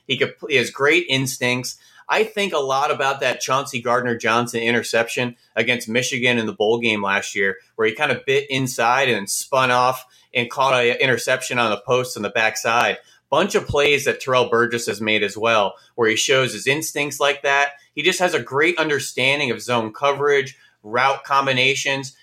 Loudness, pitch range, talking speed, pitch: -19 LUFS, 120-140 Hz, 185 wpm, 125 Hz